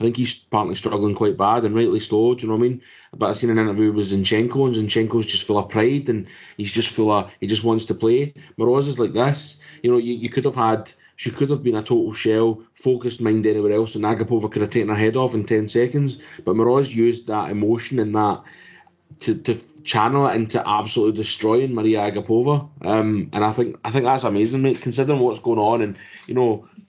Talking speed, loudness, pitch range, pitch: 230 wpm, -20 LUFS, 110-125 Hz, 115 Hz